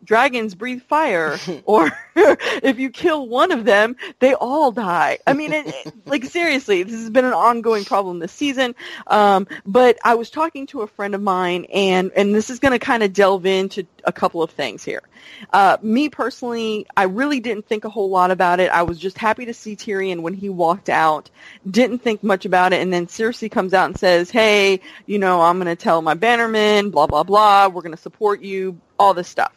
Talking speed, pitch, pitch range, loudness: 215 wpm, 210 Hz, 185-245 Hz, -17 LUFS